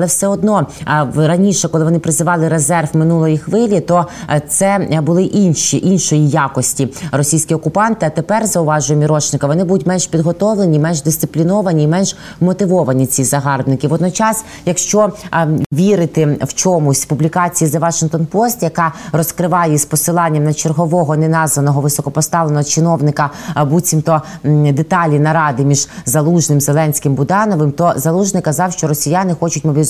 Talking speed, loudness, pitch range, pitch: 130 wpm, -13 LUFS, 150-180 Hz, 160 Hz